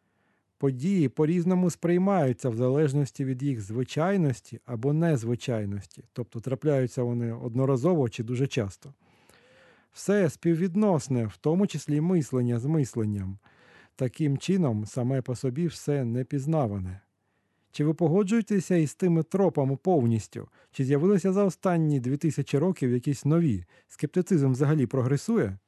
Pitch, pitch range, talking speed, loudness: 140 Hz, 125-165 Hz, 120 wpm, -27 LUFS